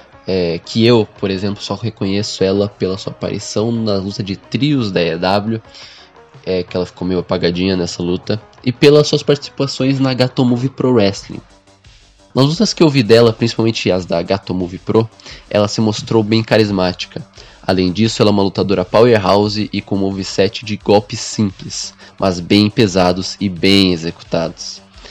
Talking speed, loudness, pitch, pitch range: 165 wpm, -15 LUFS, 100 Hz, 95-115 Hz